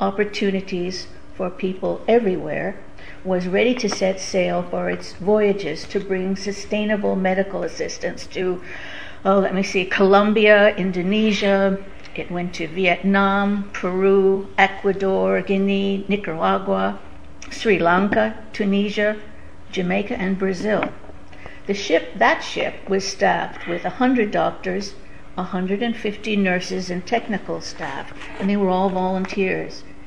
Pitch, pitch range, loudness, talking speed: 195 Hz, 180-205 Hz, -21 LUFS, 120 wpm